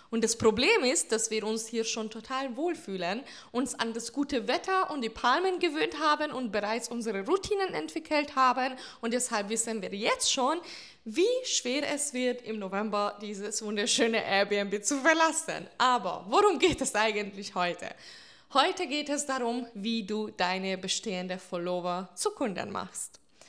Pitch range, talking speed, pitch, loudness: 210-295 Hz, 160 wpm, 235 Hz, -29 LUFS